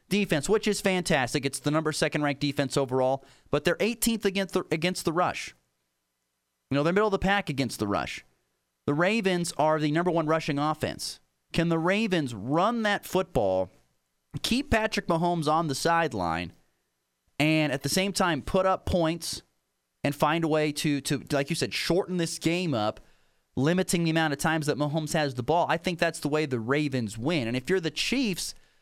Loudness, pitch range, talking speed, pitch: -27 LUFS, 135-180 Hz, 195 wpm, 155 Hz